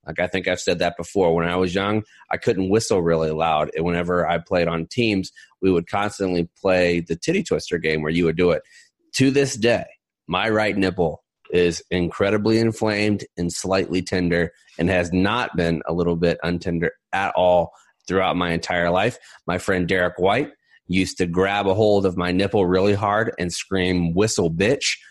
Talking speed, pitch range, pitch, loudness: 190 wpm, 85-100 Hz, 90 Hz, -21 LUFS